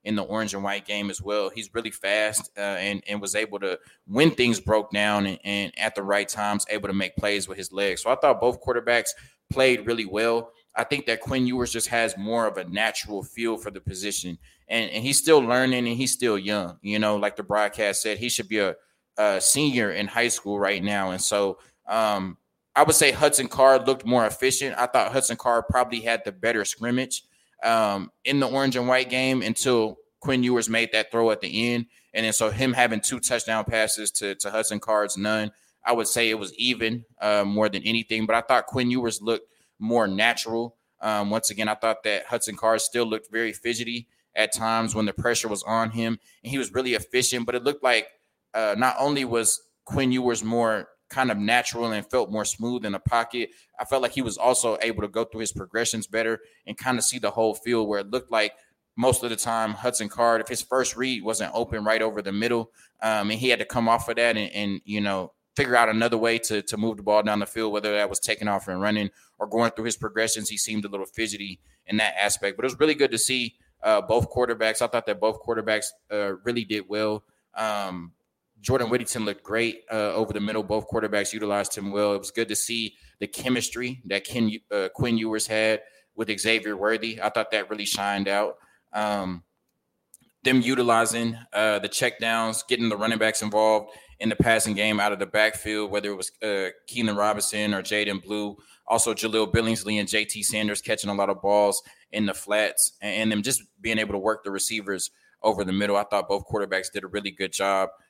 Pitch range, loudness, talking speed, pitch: 105-120 Hz, -24 LUFS, 220 wpm, 110 Hz